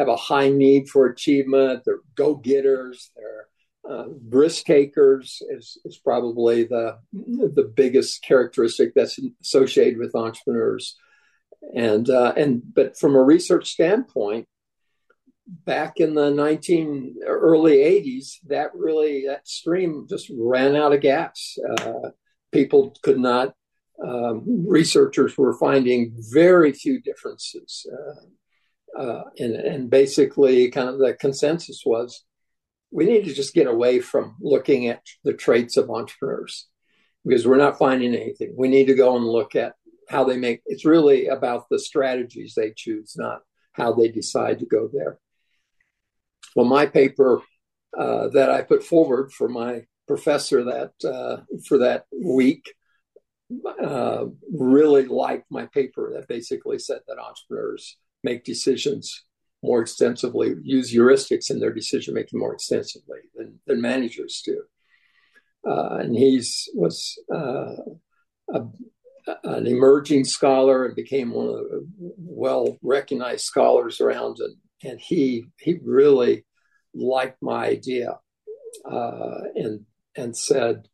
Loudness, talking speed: -21 LUFS, 135 wpm